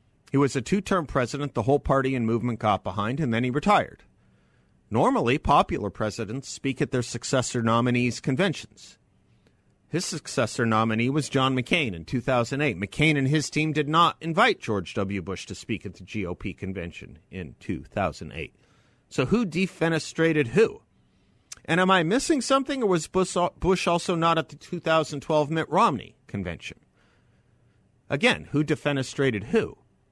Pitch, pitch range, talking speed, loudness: 135 Hz, 115-165 Hz, 150 wpm, -25 LUFS